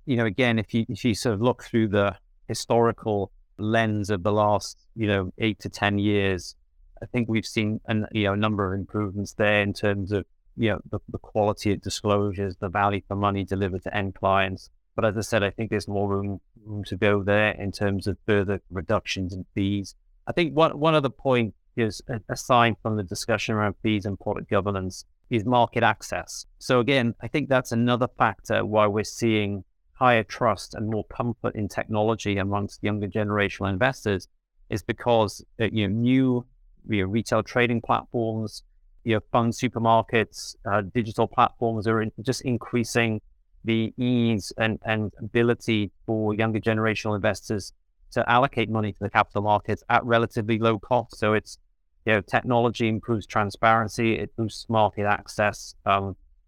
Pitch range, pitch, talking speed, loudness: 100-115 Hz, 105 Hz, 175 wpm, -25 LUFS